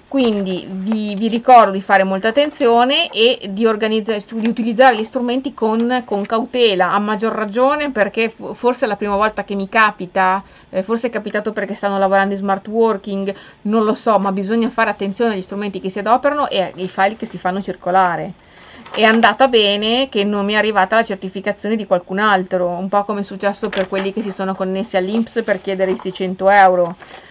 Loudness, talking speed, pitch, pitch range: -16 LUFS, 195 wpm, 205 Hz, 195-225 Hz